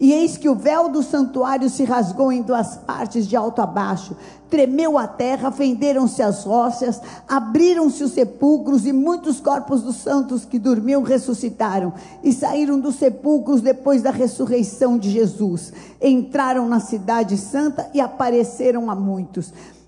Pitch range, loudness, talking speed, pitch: 230-275 Hz, -19 LUFS, 150 wpm, 255 Hz